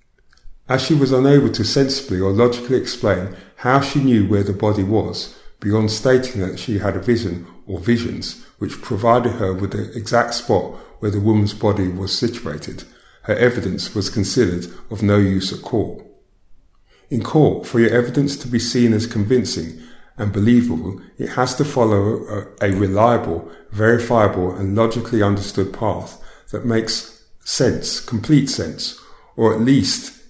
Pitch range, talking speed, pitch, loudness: 100-120 Hz, 155 wpm, 110 Hz, -18 LUFS